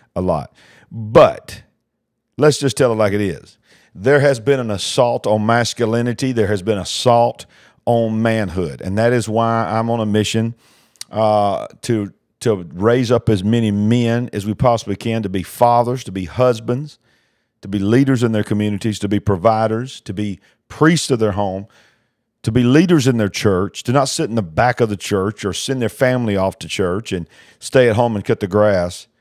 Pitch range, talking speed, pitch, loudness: 105-120 Hz, 195 wpm, 115 Hz, -17 LUFS